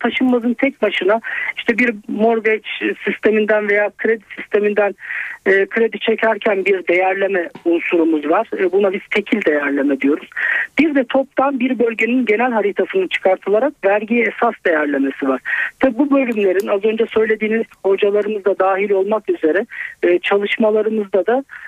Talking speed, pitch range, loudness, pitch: 135 wpm, 195-245 Hz, -17 LUFS, 215 Hz